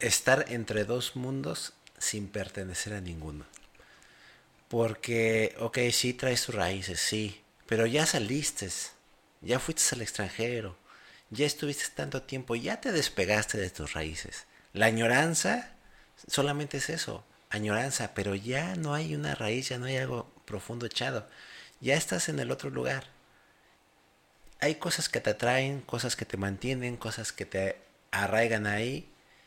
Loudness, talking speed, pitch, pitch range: -31 LUFS, 145 wpm, 115 Hz, 105-135 Hz